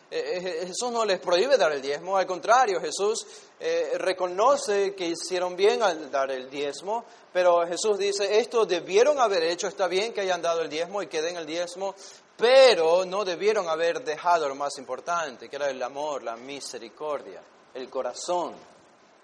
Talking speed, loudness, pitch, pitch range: 170 wpm, -25 LUFS, 185 Hz, 160-225 Hz